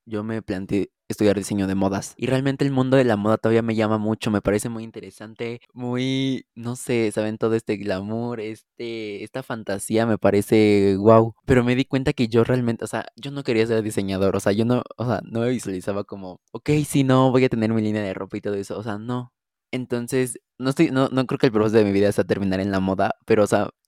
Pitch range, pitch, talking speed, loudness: 105-125 Hz, 110 Hz, 240 wpm, -22 LUFS